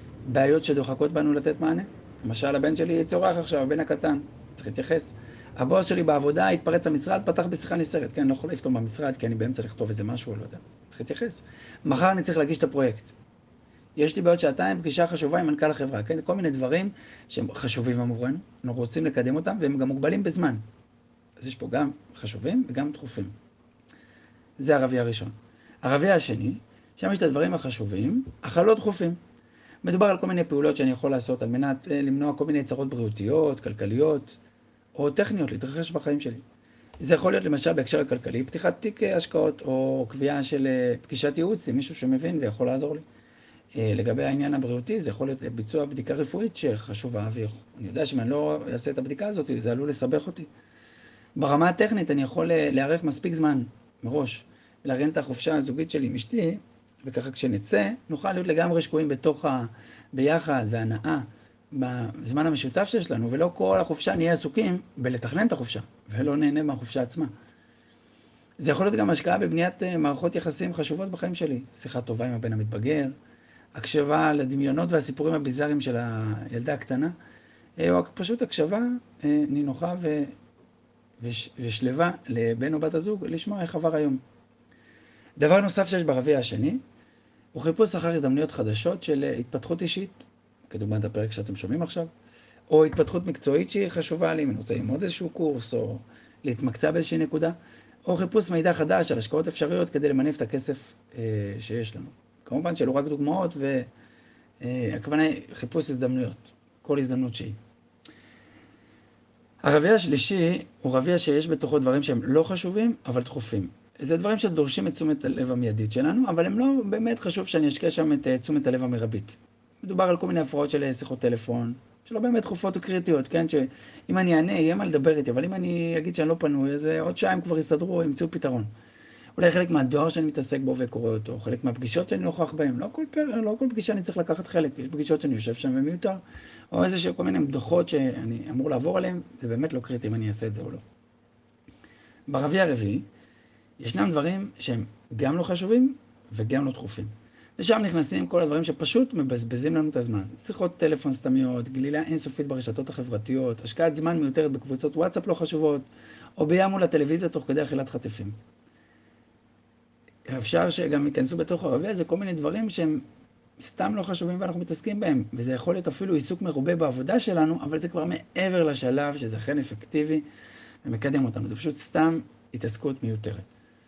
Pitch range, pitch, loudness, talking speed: 120-165 Hz, 145 Hz, -26 LUFS, 165 wpm